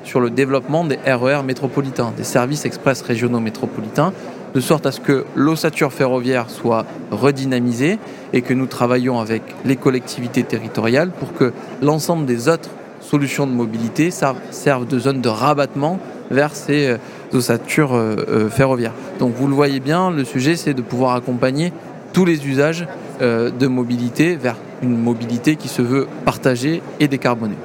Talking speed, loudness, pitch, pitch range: 160 wpm, -18 LUFS, 135 Hz, 125-145 Hz